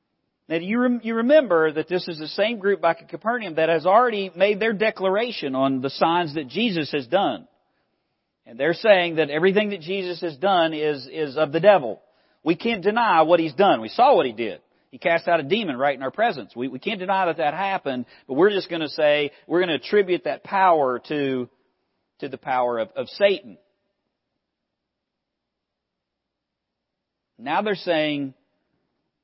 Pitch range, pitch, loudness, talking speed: 155-200 Hz, 175 Hz, -22 LUFS, 185 wpm